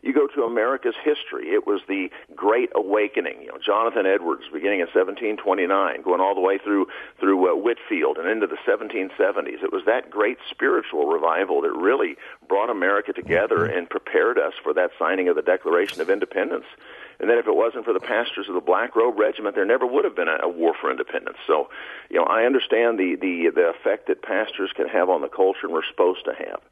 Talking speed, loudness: 215 wpm, -22 LUFS